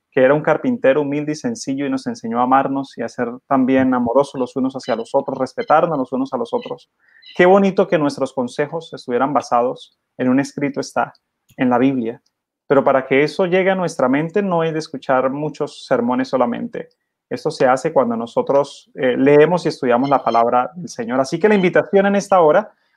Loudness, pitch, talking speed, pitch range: -17 LUFS, 140 Hz, 200 wpm, 130-175 Hz